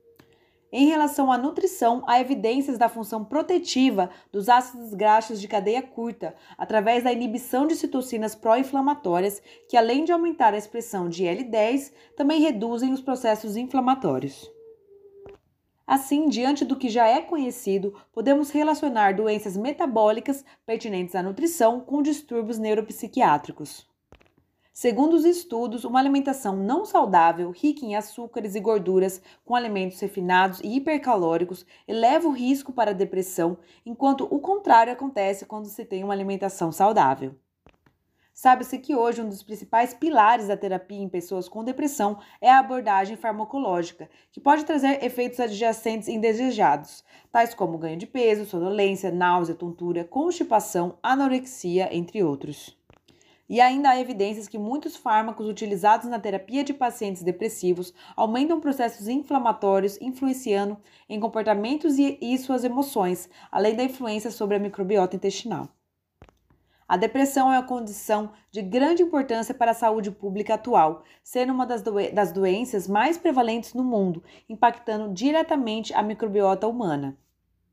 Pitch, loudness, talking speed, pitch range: 230 Hz, -24 LUFS, 135 wpm, 200-265 Hz